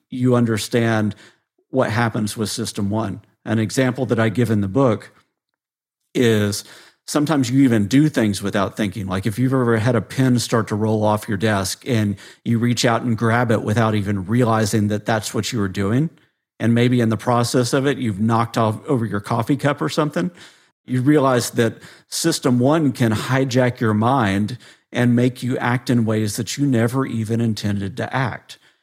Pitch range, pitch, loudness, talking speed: 110-130 Hz, 115 Hz, -19 LUFS, 185 wpm